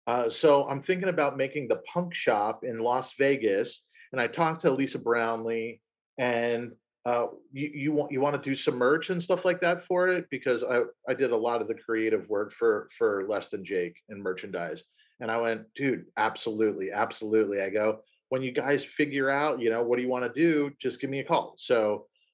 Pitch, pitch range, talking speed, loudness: 140 Hz, 120-180 Hz, 210 wpm, -28 LUFS